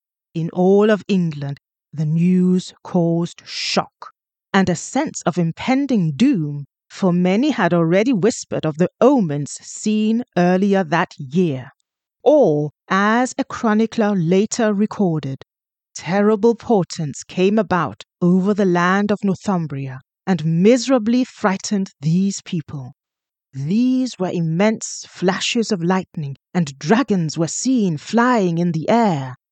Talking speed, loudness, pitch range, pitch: 120 wpm, -18 LUFS, 165-215 Hz, 185 Hz